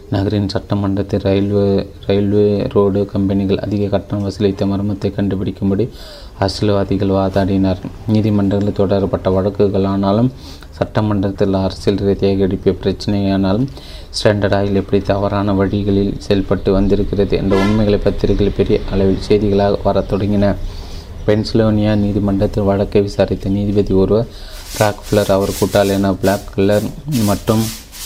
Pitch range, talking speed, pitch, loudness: 95-105 Hz, 105 wpm, 100 Hz, -16 LUFS